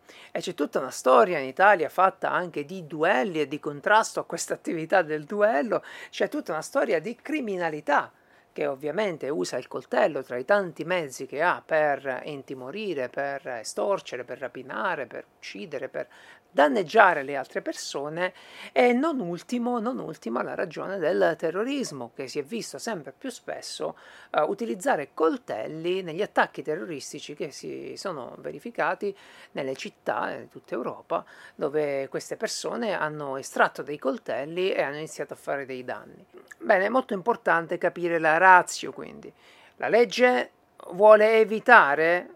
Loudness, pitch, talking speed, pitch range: -25 LUFS, 180 Hz, 150 wpm, 150-220 Hz